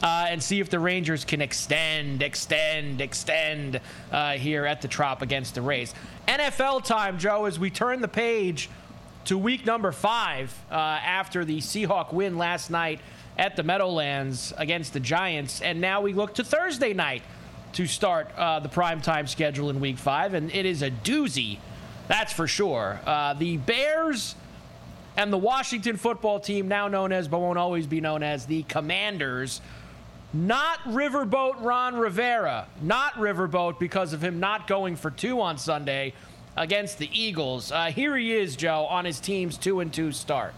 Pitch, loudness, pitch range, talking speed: 175 Hz, -26 LUFS, 150-205 Hz, 170 wpm